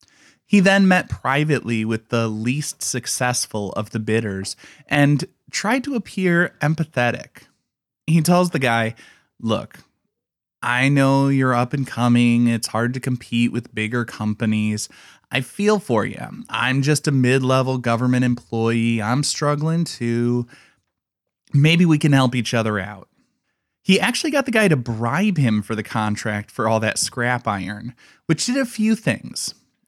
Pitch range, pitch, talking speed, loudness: 115-150 Hz, 125 Hz, 155 wpm, -20 LUFS